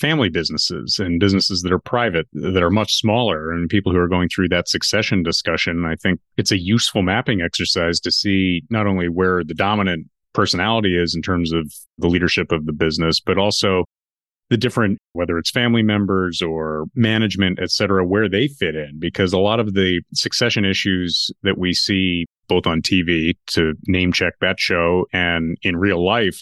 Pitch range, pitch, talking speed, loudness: 85-100 Hz, 90 Hz, 185 wpm, -18 LUFS